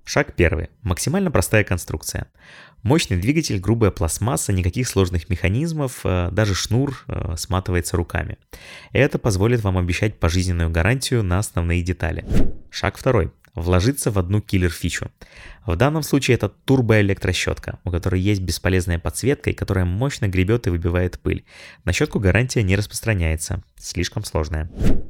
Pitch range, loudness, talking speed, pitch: 90-115 Hz, -21 LUFS, 130 wpm, 95 Hz